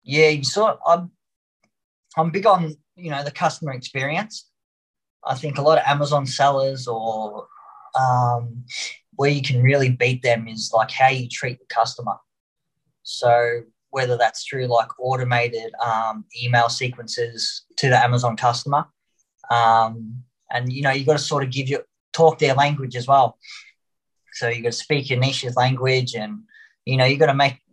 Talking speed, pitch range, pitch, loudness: 165 wpm, 120-145 Hz, 130 Hz, -20 LUFS